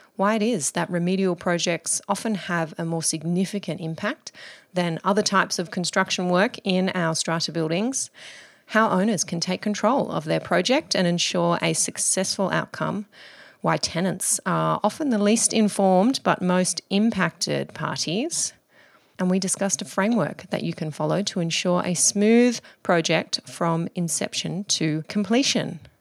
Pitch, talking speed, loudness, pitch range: 185 Hz, 150 wpm, -23 LUFS, 170-210 Hz